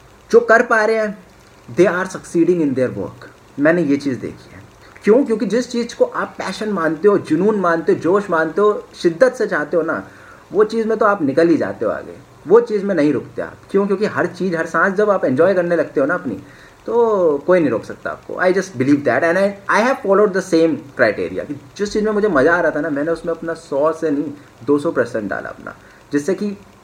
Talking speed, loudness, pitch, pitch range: 235 wpm, -17 LUFS, 190 Hz, 160-215 Hz